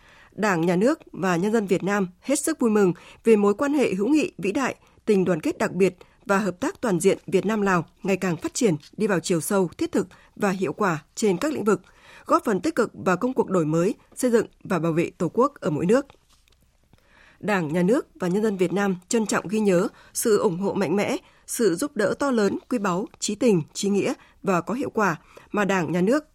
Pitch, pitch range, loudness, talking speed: 205 Hz, 185-235 Hz, -24 LUFS, 240 wpm